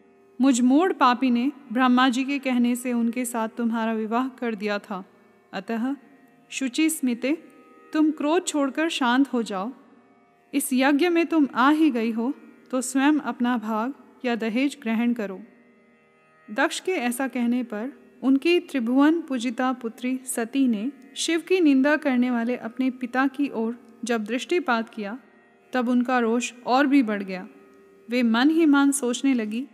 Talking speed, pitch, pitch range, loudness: 155 wpm, 250 Hz, 230-275 Hz, -24 LUFS